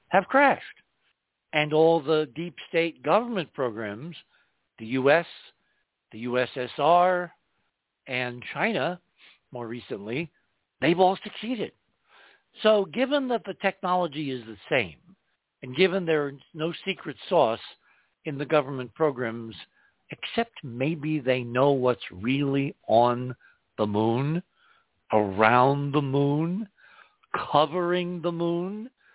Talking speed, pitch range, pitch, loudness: 110 wpm, 125-180 Hz, 155 Hz, -26 LUFS